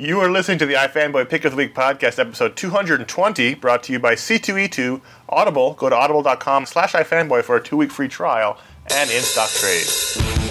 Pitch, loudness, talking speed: 155 Hz, -18 LUFS, 190 wpm